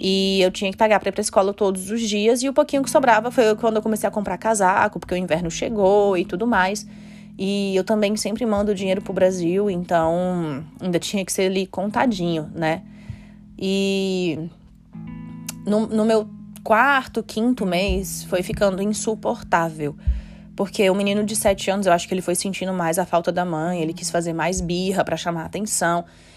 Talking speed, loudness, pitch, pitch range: 190 wpm, -21 LUFS, 195 Hz, 175-210 Hz